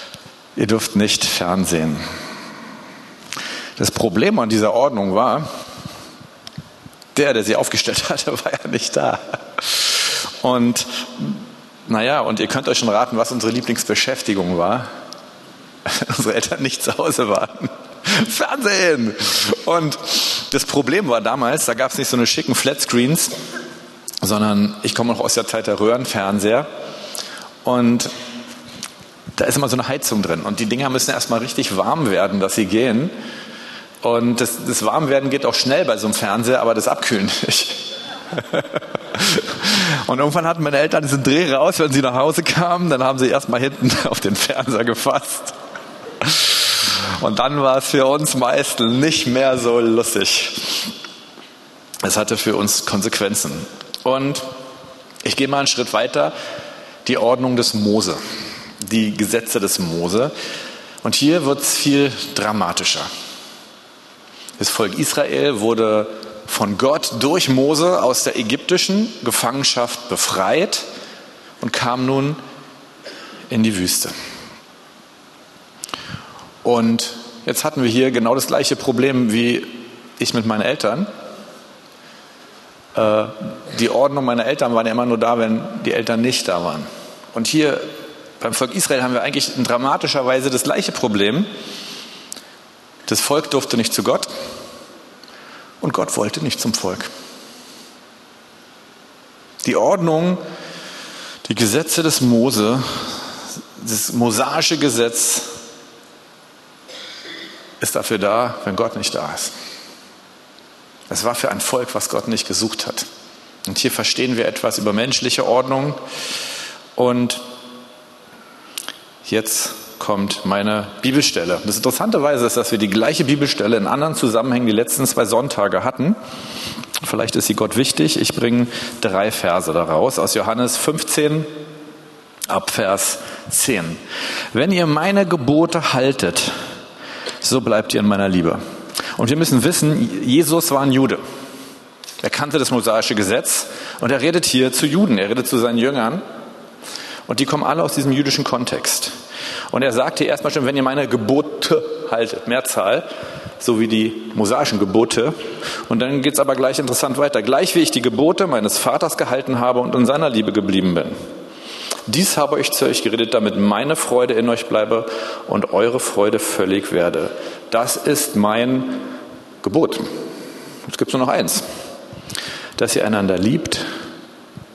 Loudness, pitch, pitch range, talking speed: -18 LUFS, 125 Hz, 115-145 Hz, 140 wpm